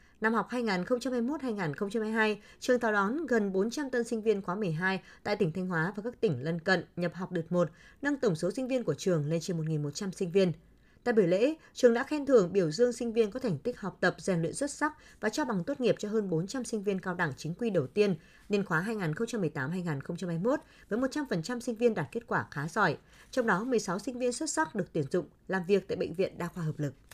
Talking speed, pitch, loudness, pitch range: 230 wpm, 205 Hz, -31 LUFS, 175-240 Hz